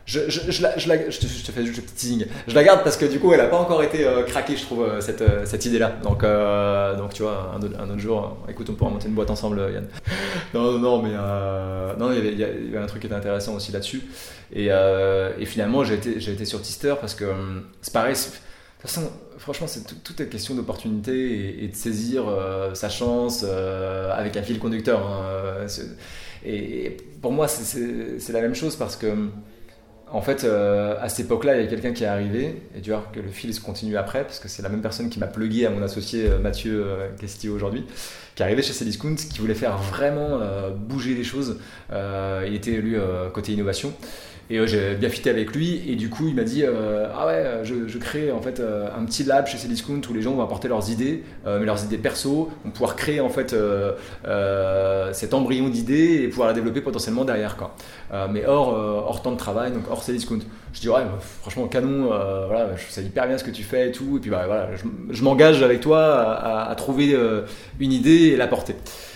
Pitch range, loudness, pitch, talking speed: 100-125 Hz, -23 LUFS, 110 Hz, 240 wpm